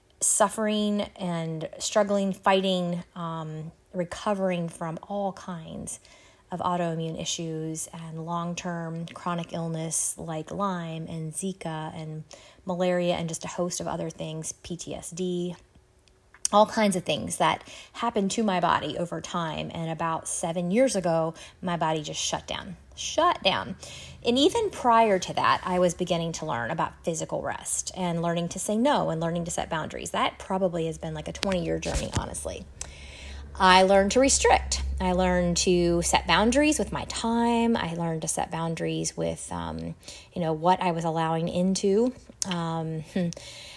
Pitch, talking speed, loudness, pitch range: 175 Hz, 155 wpm, -27 LUFS, 160-190 Hz